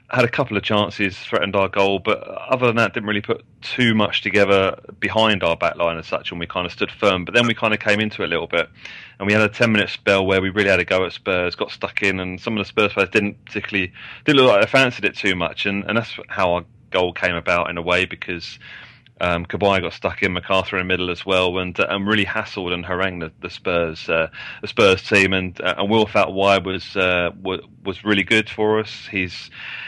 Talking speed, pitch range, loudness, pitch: 250 wpm, 90-105 Hz, -19 LUFS, 100 Hz